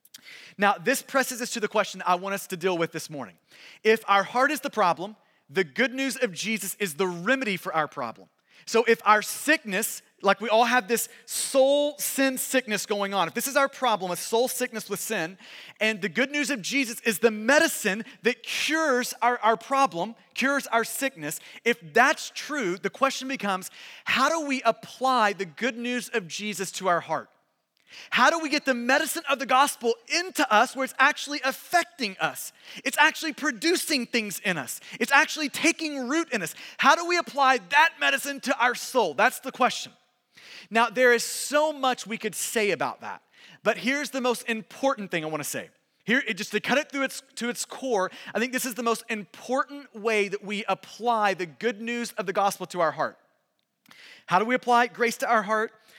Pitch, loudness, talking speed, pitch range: 235 Hz, -25 LUFS, 205 wpm, 200-270 Hz